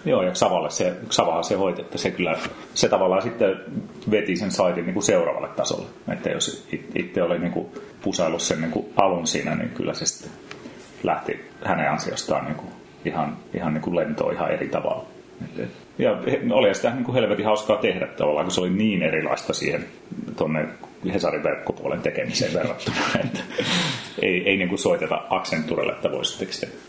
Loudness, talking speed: -24 LUFS, 175 wpm